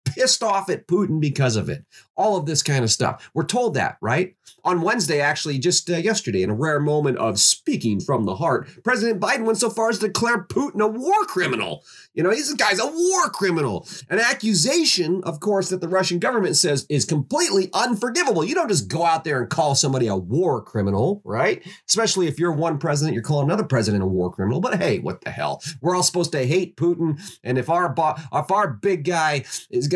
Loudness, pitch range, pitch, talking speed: -21 LUFS, 145-210 Hz, 170 Hz, 215 wpm